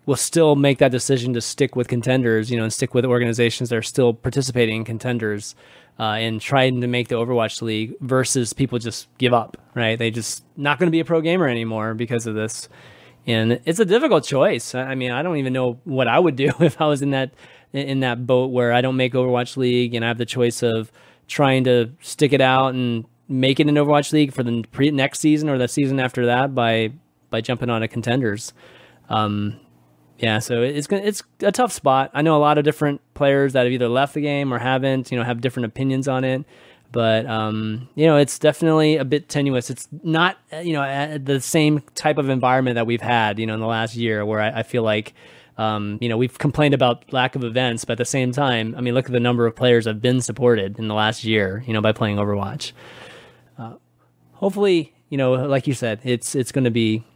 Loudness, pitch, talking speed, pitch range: -20 LUFS, 125 Hz, 230 wpm, 115-140 Hz